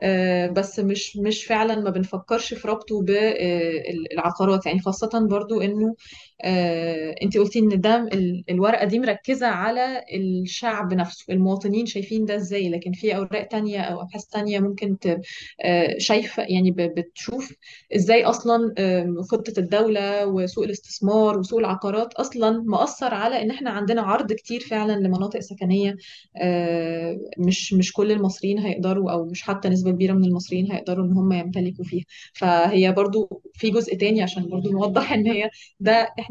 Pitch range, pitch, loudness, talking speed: 185-220 Hz, 200 Hz, -22 LUFS, 145 wpm